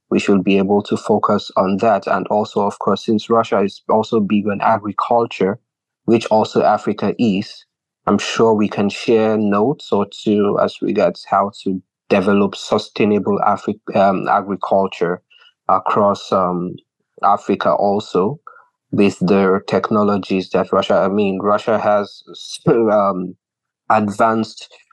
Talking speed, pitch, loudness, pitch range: 130 wpm, 105 Hz, -17 LUFS, 100-110 Hz